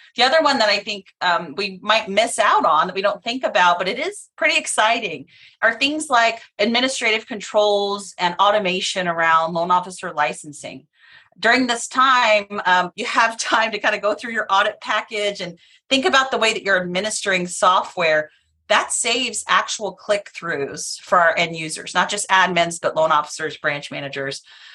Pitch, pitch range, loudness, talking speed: 205 Hz, 180-235 Hz, -19 LUFS, 180 wpm